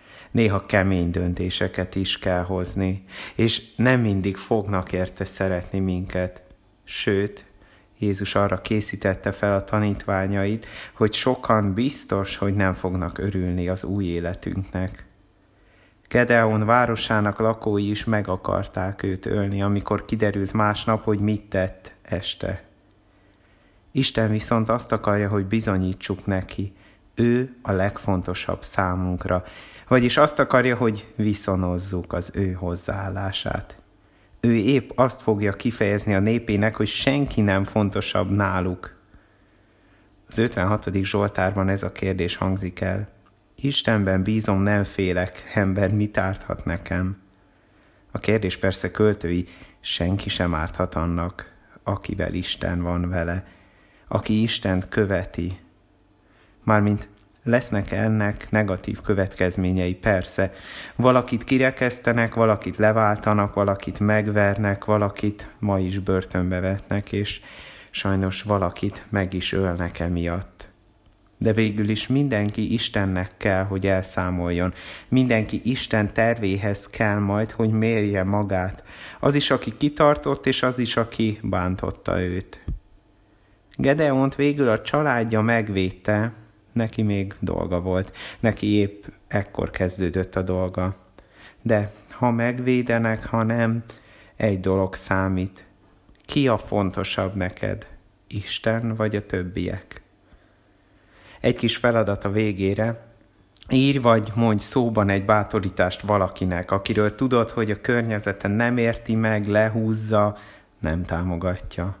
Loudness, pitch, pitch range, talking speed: -23 LUFS, 100 Hz, 95-110 Hz, 115 wpm